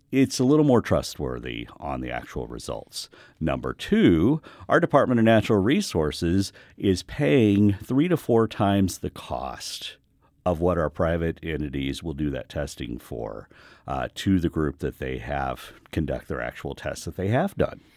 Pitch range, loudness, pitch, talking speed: 75-105 Hz, -25 LUFS, 90 Hz, 165 wpm